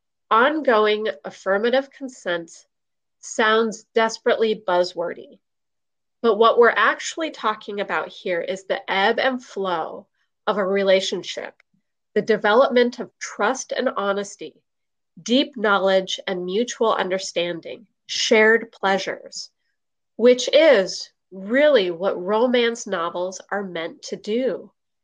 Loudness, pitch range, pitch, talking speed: -21 LUFS, 190-235 Hz, 215 Hz, 105 wpm